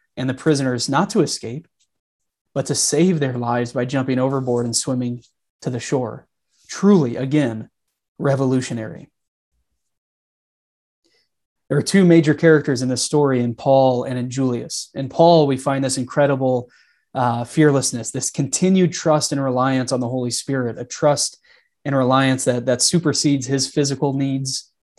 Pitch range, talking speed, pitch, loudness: 125-145 Hz, 150 wpm, 135 Hz, -19 LUFS